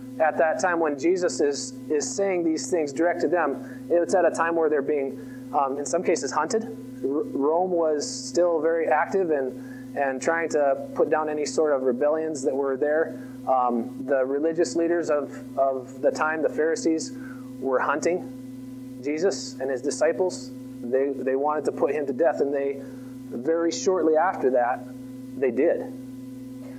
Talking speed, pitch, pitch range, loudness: 170 wpm, 140 Hz, 130-165 Hz, -25 LUFS